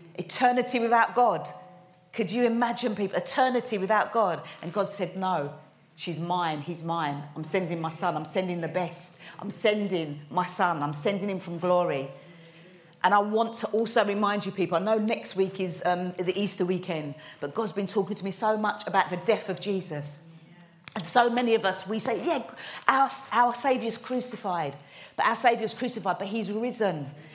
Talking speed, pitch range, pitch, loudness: 185 wpm, 170-220 Hz, 190 Hz, -27 LUFS